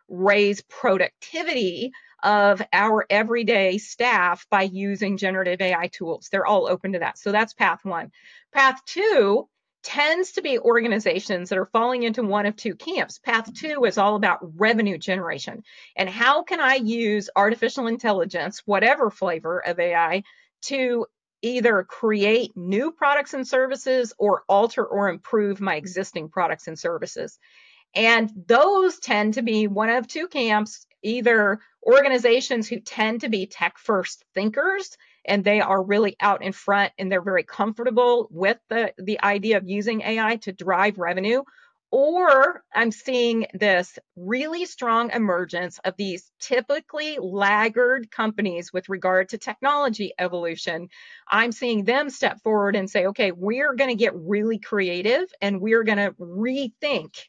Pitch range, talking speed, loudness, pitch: 195-250 Hz, 150 wpm, -22 LUFS, 215 Hz